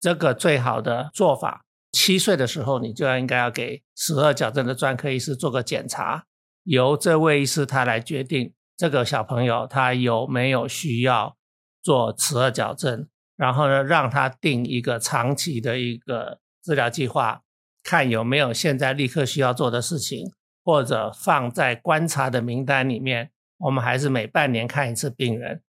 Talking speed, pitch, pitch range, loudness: 260 characters per minute, 130 Hz, 125-145 Hz, -22 LUFS